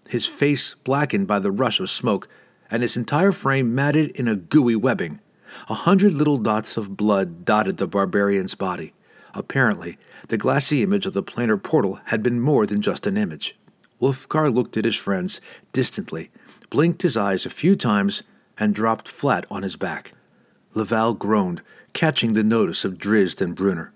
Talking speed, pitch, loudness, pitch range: 175 wpm, 115 Hz, -21 LUFS, 105-150 Hz